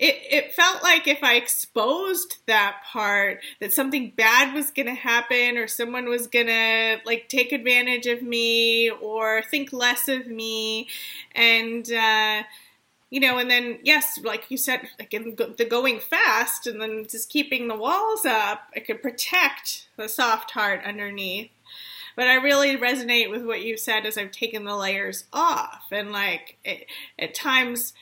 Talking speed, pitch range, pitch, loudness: 165 wpm, 220-265 Hz, 235 Hz, -22 LUFS